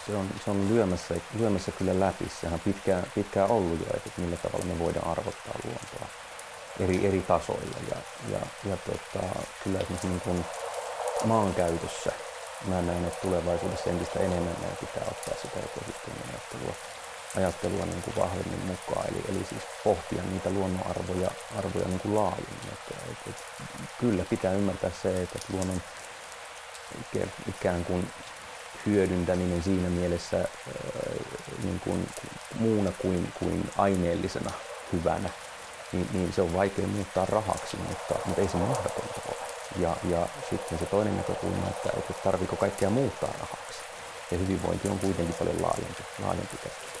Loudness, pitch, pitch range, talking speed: -31 LUFS, 95 Hz, 90-100 Hz, 145 wpm